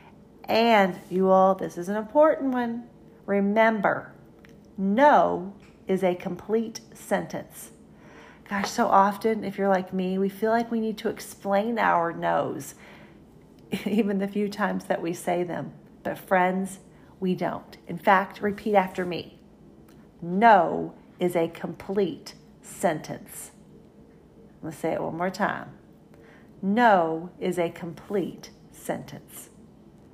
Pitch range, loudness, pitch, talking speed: 185-210 Hz, -25 LUFS, 195 Hz, 125 wpm